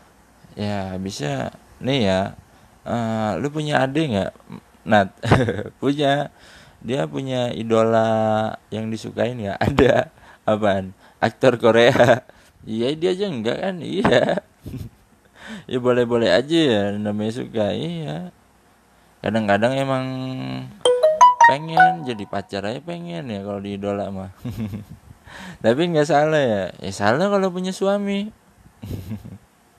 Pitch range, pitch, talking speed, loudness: 105-150 Hz, 115 Hz, 110 wpm, -20 LUFS